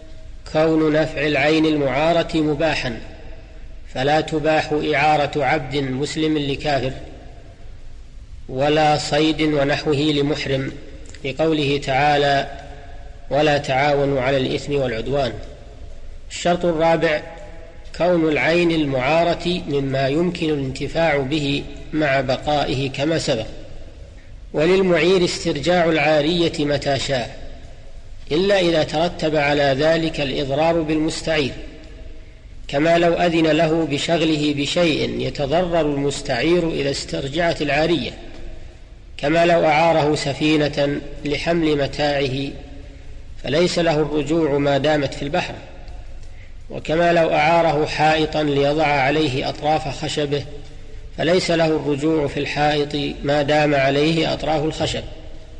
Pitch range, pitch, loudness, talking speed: 140-160 Hz, 150 Hz, -19 LUFS, 95 wpm